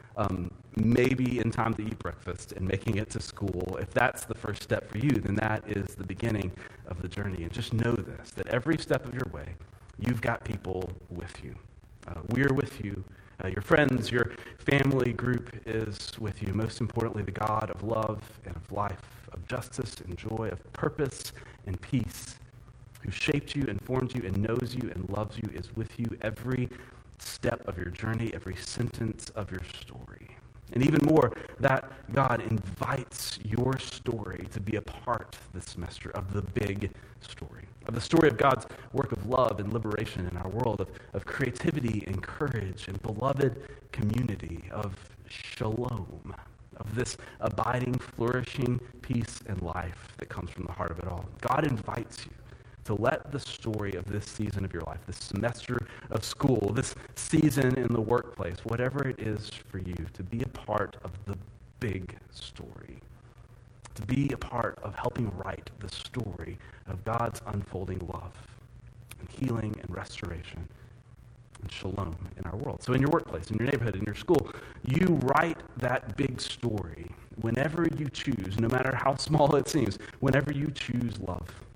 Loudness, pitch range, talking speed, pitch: -31 LUFS, 100-125 Hz, 175 wpm, 115 Hz